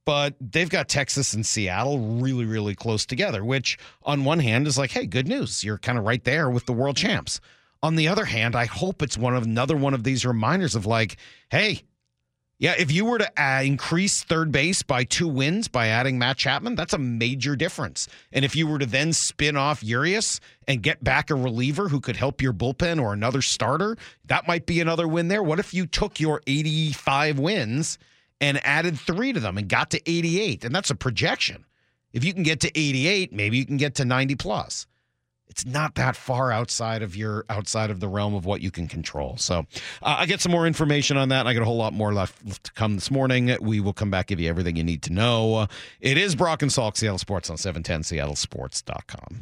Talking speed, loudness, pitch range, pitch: 220 wpm, -24 LUFS, 110-155 Hz, 135 Hz